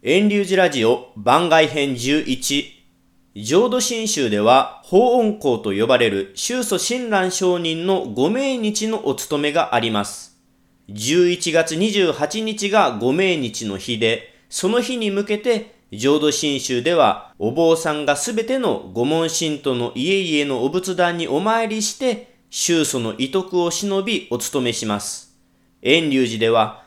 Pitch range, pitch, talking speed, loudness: 120-205 Hz, 160 Hz, 245 characters per minute, -19 LUFS